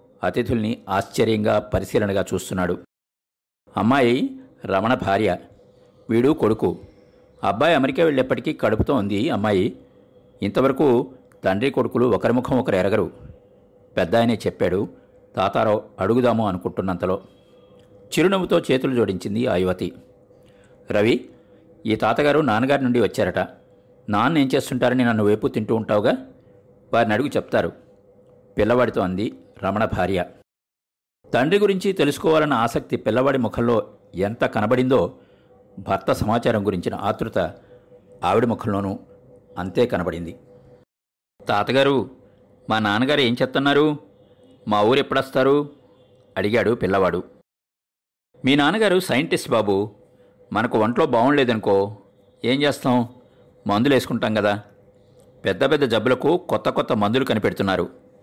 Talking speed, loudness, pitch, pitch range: 100 wpm, -21 LUFS, 115 Hz, 100-130 Hz